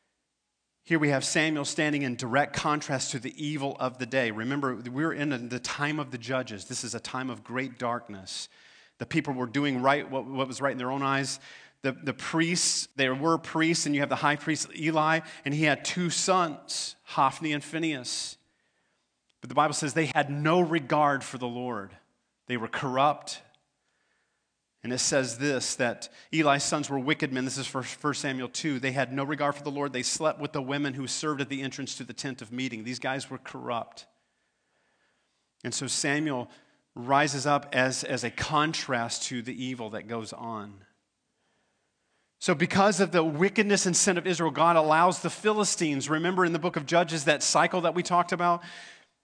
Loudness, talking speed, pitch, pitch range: -28 LUFS, 195 wpm, 140 Hz, 130-160 Hz